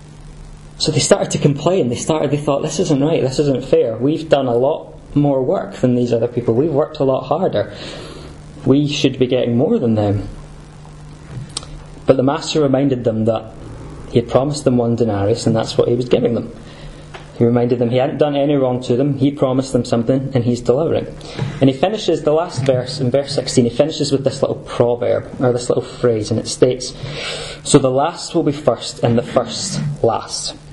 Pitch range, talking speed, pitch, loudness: 120-145 Hz, 205 wpm, 135 Hz, -17 LUFS